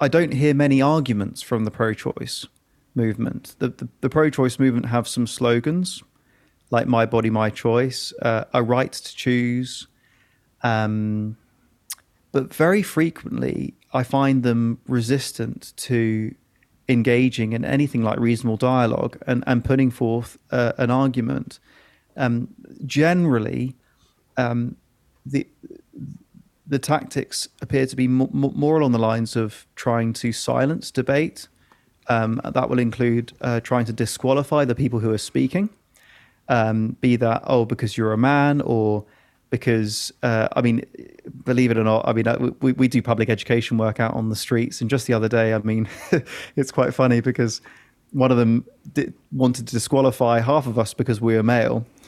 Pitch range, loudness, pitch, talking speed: 115-130 Hz, -21 LUFS, 120 Hz, 155 wpm